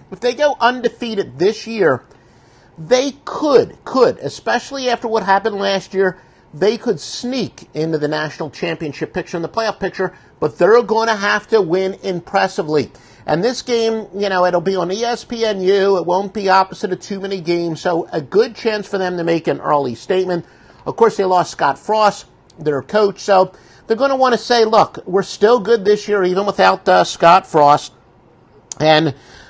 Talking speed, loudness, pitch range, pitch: 185 wpm, -16 LUFS, 165-225 Hz, 195 Hz